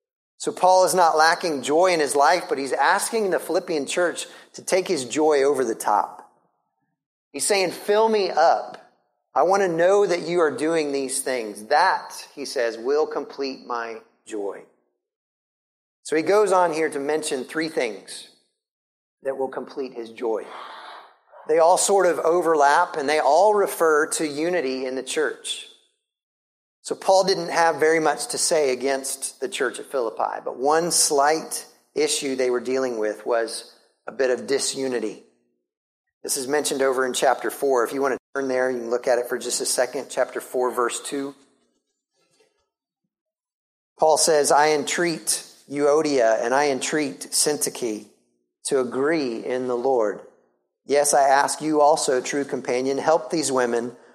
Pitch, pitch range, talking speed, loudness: 145 Hz, 130-180 Hz, 165 wpm, -22 LUFS